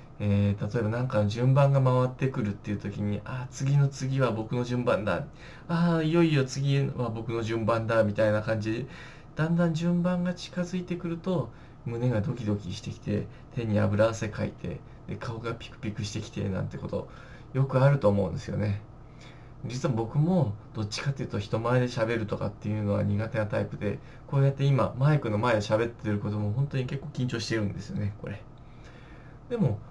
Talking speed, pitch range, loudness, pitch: 370 characters per minute, 110-140 Hz, -28 LUFS, 120 Hz